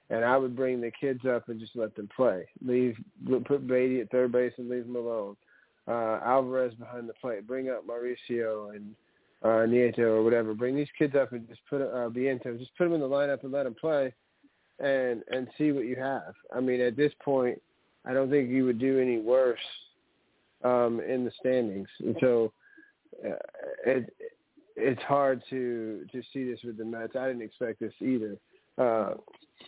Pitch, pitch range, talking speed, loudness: 125 Hz, 115-135 Hz, 190 wpm, -30 LUFS